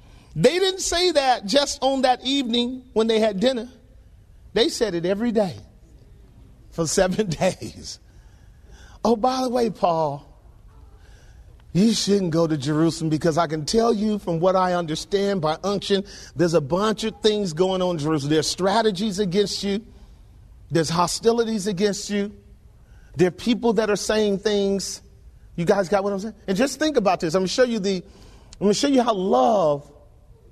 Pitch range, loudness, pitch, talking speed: 155-220 Hz, -22 LUFS, 195 Hz, 170 wpm